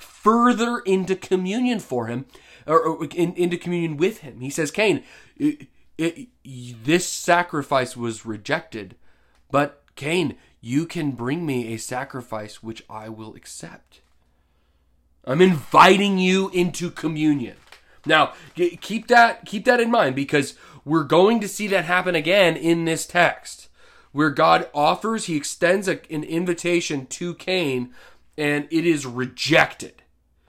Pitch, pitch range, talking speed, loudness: 160 Hz, 125-180 Hz, 130 wpm, -21 LUFS